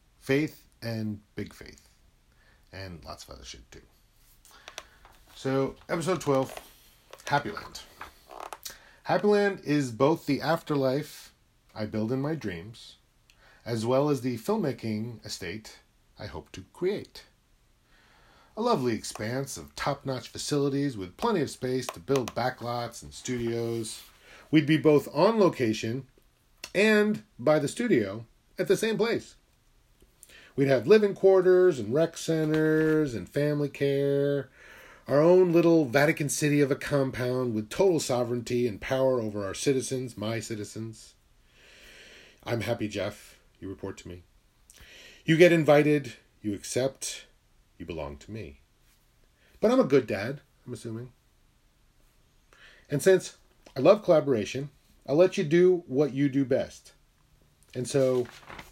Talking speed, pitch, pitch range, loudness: 130 wpm, 130 Hz, 115-150 Hz, -27 LUFS